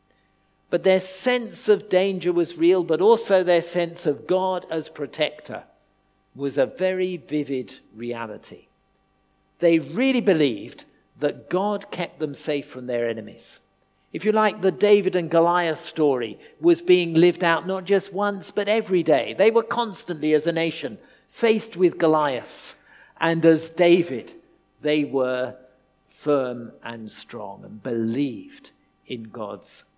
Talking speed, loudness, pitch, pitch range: 140 wpm, -22 LUFS, 170 Hz, 140-190 Hz